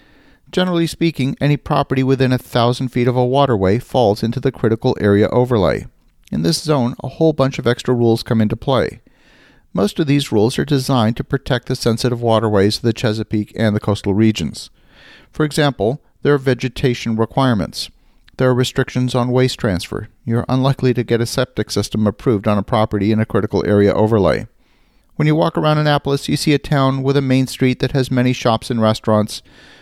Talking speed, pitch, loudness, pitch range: 190 wpm, 125 Hz, -17 LUFS, 110-135 Hz